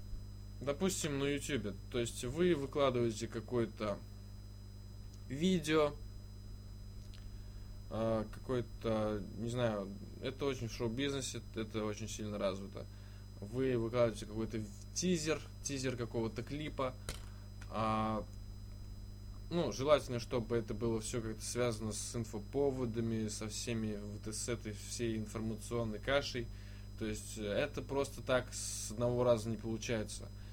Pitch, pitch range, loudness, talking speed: 110 Hz, 100-120 Hz, -38 LUFS, 110 wpm